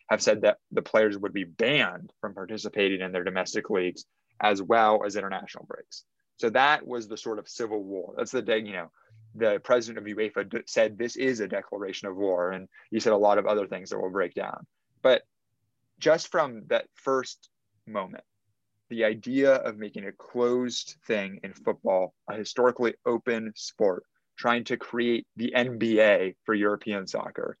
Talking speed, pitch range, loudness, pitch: 180 wpm, 100-120 Hz, -27 LUFS, 110 Hz